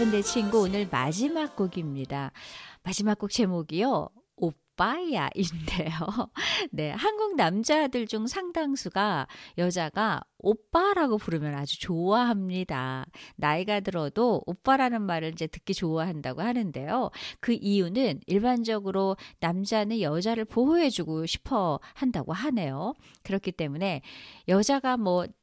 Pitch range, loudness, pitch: 170-235 Hz, -28 LUFS, 195 Hz